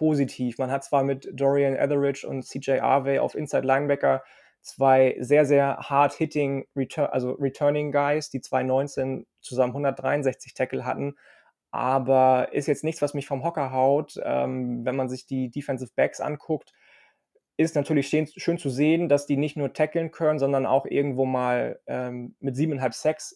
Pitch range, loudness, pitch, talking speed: 130-145 Hz, -25 LUFS, 135 Hz, 165 wpm